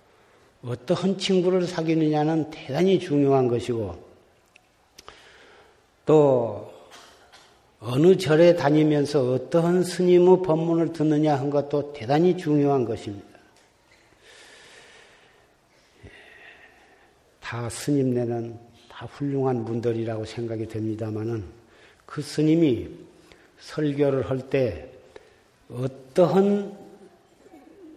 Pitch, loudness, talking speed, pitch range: 145 Hz, -23 LUFS, 185 characters per minute, 120-180 Hz